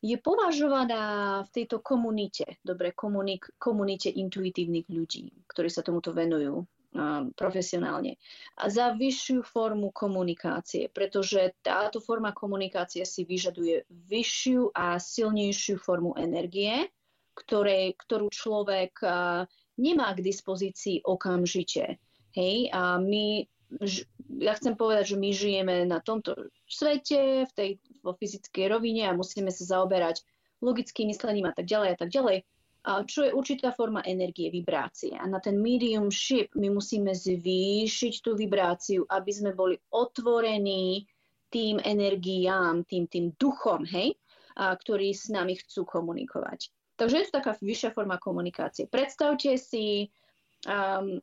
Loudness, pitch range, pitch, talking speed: -29 LUFS, 185-230 Hz, 200 Hz, 130 wpm